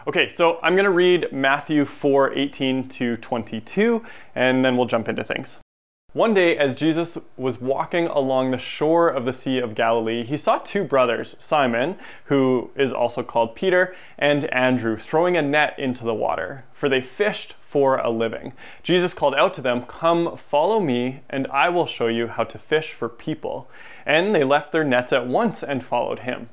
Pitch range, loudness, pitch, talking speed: 125-160 Hz, -21 LUFS, 135 Hz, 185 wpm